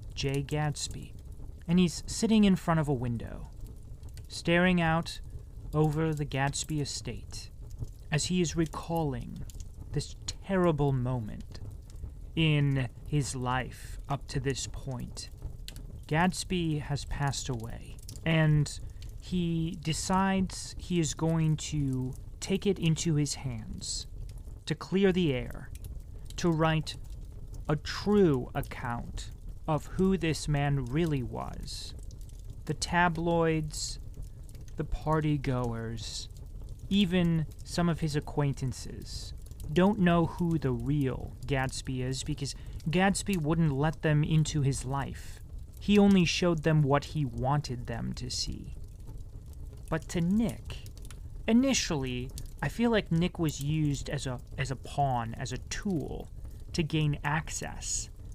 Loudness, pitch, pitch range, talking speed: -30 LUFS, 140 Hz, 115-160 Hz, 120 wpm